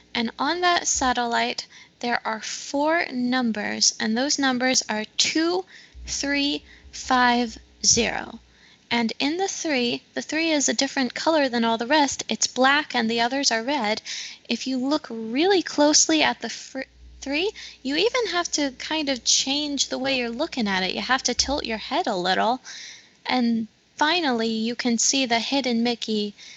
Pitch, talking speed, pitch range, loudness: 260 Hz, 170 wpm, 235-295 Hz, -23 LUFS